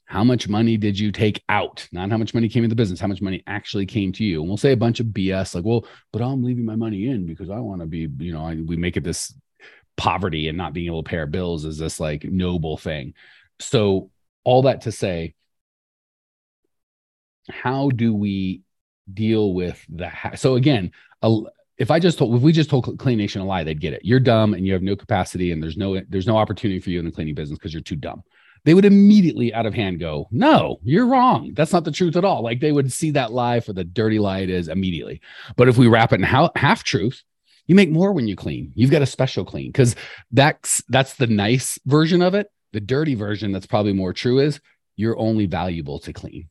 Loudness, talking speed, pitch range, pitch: -20 LUFS, 240 wpm, 90-125 Hz, 105 Hz